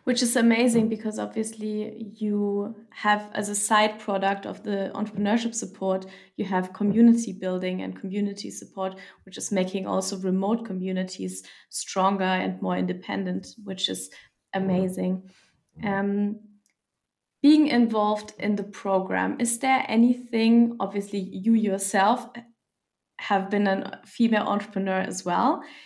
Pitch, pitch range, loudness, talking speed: 205 Hz, 190-220 Hz, -25 LUFS, 125 wpm